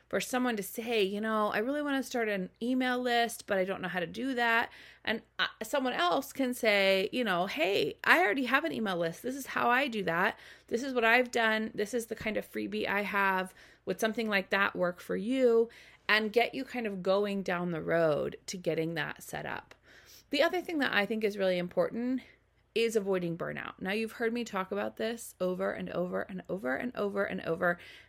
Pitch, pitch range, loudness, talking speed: 215 Hz, 190-240 Hz, -31 LUFS, 220 wpm